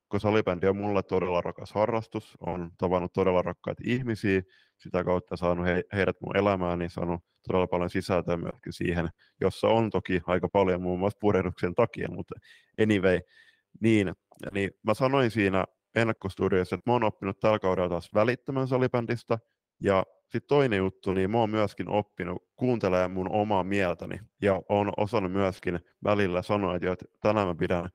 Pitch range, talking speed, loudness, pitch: 90-110 Hz, 160 wpm, -28 LUFS, 95 Hz